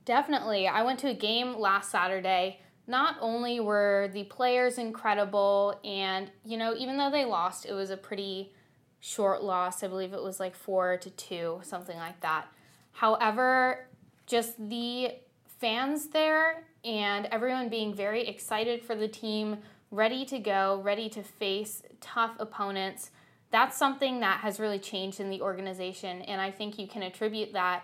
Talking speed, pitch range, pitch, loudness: 160 wpm, 195-235 Hz, 210 Hz, -30 LUFS